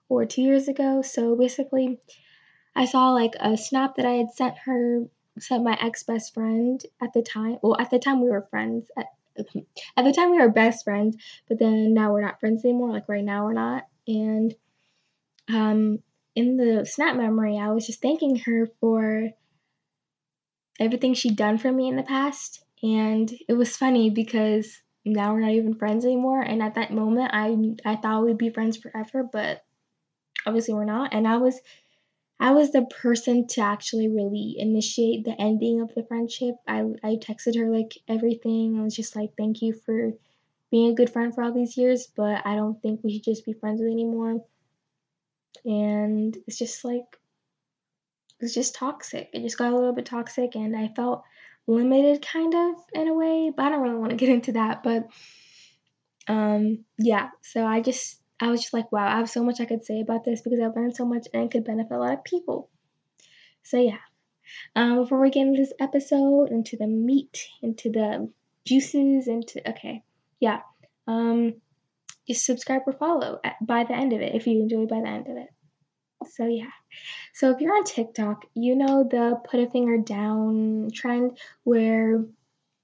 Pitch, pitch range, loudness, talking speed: 230 Hz, 220-250 Hz, -24 LUFS, 190 wpm